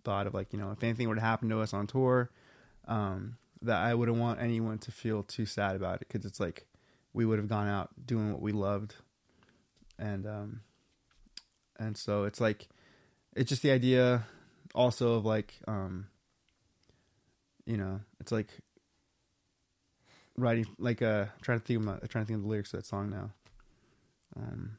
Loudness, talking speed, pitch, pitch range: -33 LUFS, 170 wpm, 110 Hz, 100-115 Hz